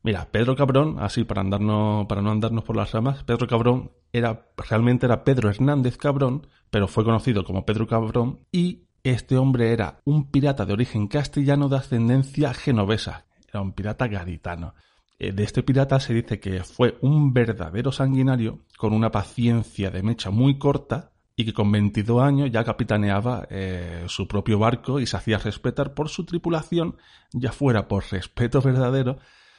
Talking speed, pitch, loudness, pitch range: 170 wpm, 115 Hz, -23 LUFS, 105-135 Hz